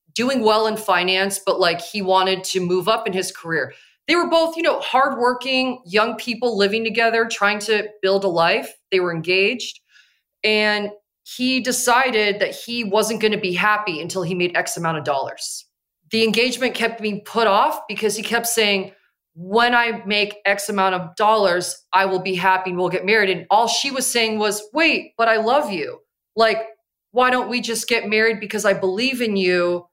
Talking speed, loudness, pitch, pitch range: 195 wpm, -19 LUFS, 215 Hz, 190-235 Hz